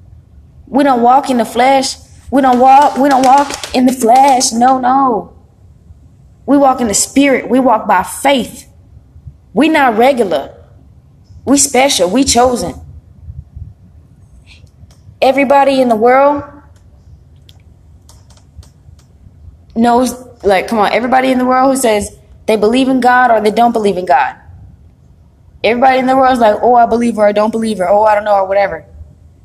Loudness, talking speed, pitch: -10 LUFS, 155 wpm, 225 Hz